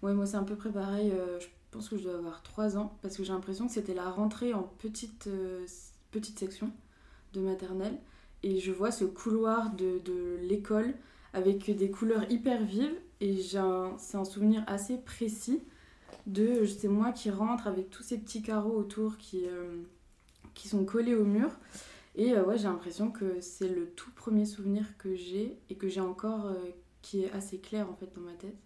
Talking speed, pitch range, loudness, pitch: 205 wpm, 190-220 Hz, -34 LUFS, 205 Hz